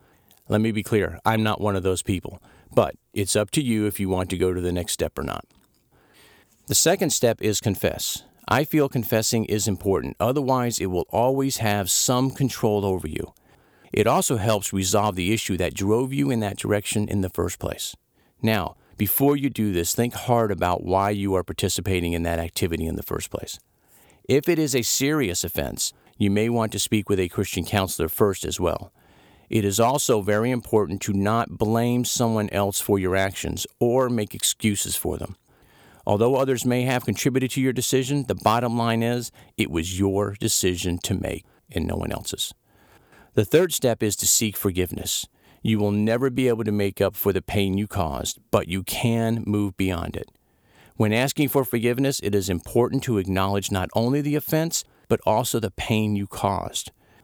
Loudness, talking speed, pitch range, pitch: -23 LUFS, 190 wpm, 95-120 Hz, 105 Hz